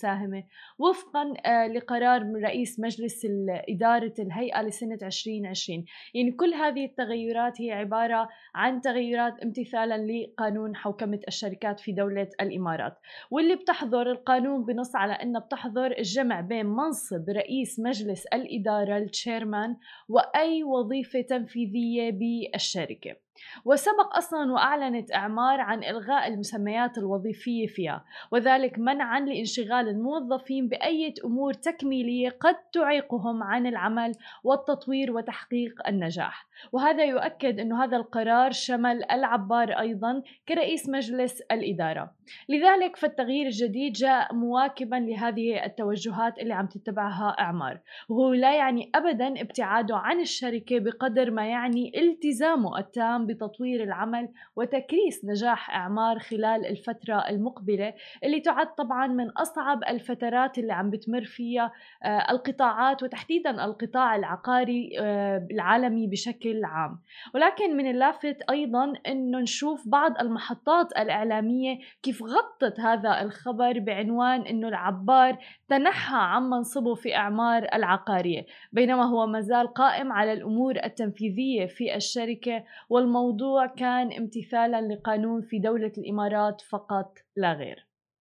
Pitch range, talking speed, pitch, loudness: 220-260 Hz, 115 wpm, 235 Hz, -27 LUFS